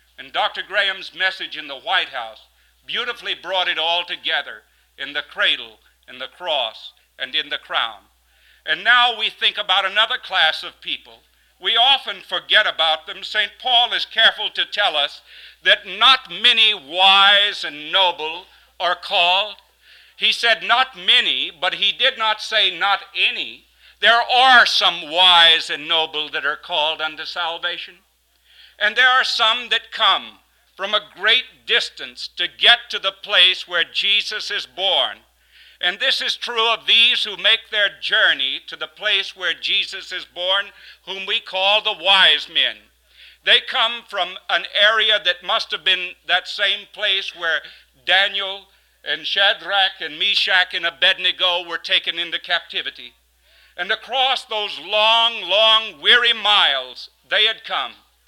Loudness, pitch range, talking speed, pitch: -17 LUFS, 175-220 Hz, 155 wpm, 195 Hz